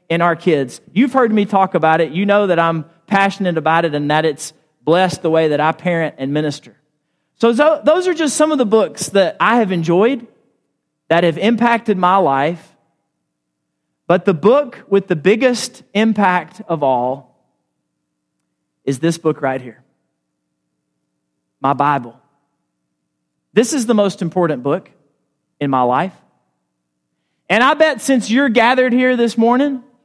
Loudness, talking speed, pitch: -15 LUFS, 155 wpm, 165 Hz